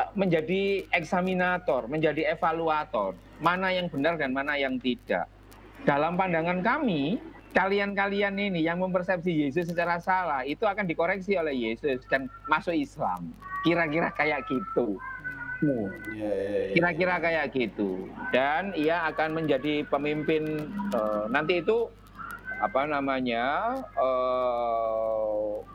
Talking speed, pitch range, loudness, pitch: 105 wpm, 140-190 Hz, -28 LUFS, 165 Hz